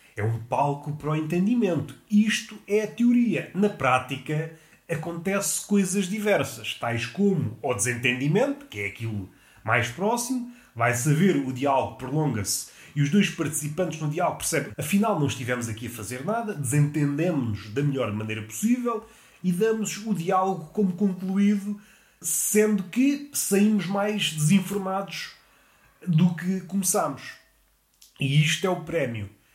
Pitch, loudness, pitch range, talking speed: 165 Hz, -25 LUFS, 135-205 Hz, 135 wpm